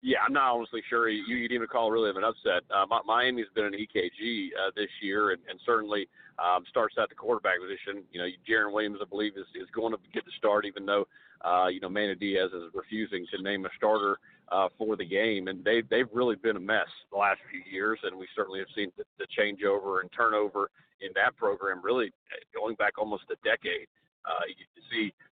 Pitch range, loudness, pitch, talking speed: 100-120 Hz, -30 LUFS, 110 Hz, 230 wpm